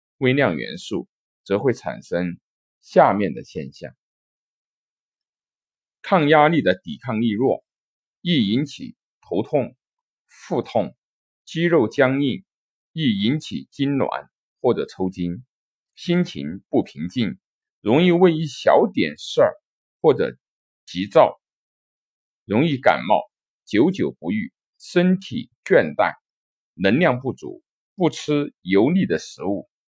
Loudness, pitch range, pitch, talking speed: -21 LUFS, 135-205 Hz, 160 Hz, 165 characters per minute